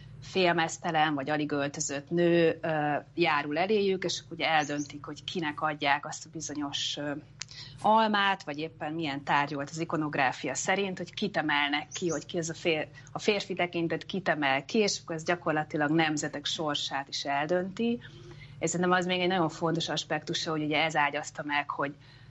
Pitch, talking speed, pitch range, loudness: 155 Hz, 165 wpm, 145-170 Hz, -29 LUFS